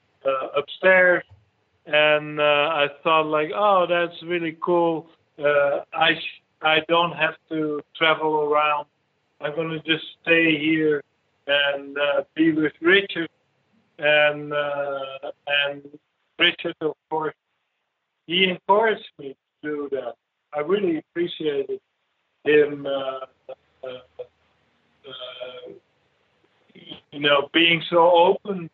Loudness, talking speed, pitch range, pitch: -21 LUFS, 115 wpm, 145-170 Hz, 155 Hz